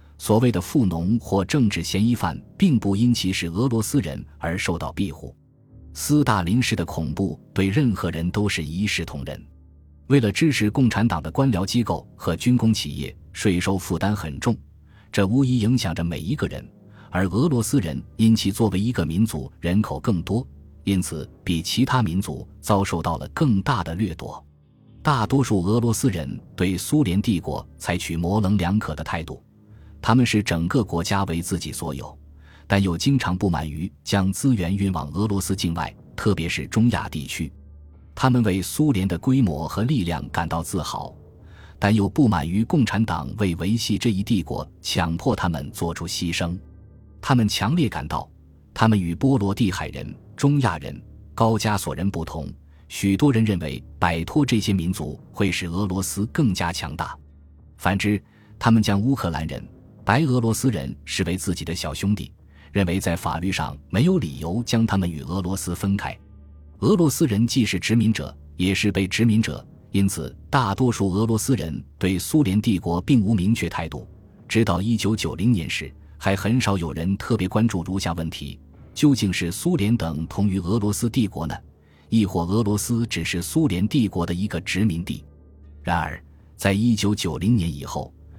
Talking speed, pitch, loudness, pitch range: 260 characters per minute, 95 Hz, -23 LUFS, 80-110 Hz